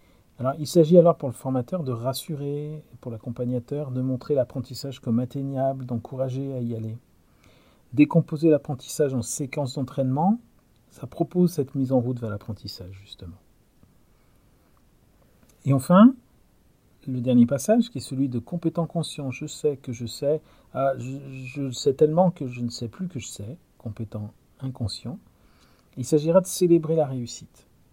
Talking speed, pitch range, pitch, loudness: 150 wpm, 120-155 Hz, 135 Hz, -24 LUFS